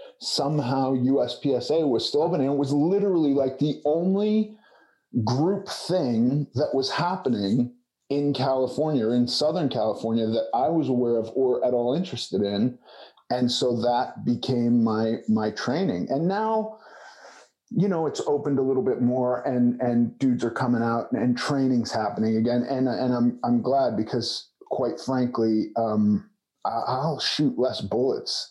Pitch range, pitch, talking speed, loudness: 120-145 Hz, 130 Hz, 150 wpm, -24 LUFS